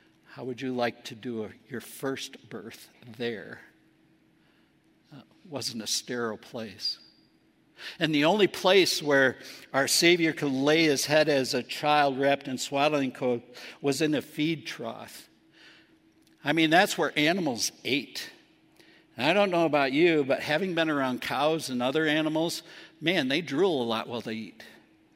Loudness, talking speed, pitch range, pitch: -26 LUFS, 160 wpm, 125-155 Hz, 140 Hz